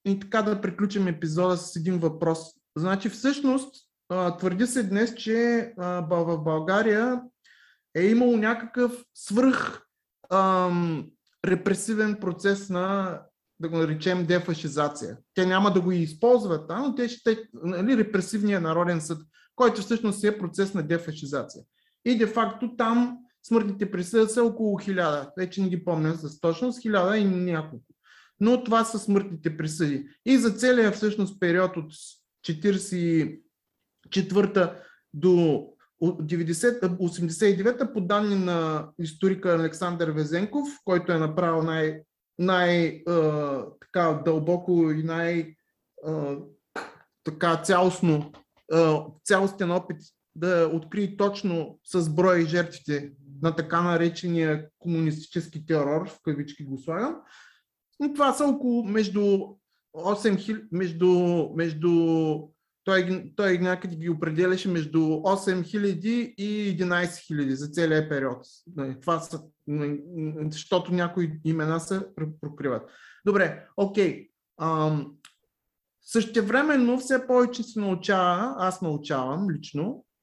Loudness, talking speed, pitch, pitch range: -26 LUFS, 110 wpm, 180 Hz, 160-210 Hz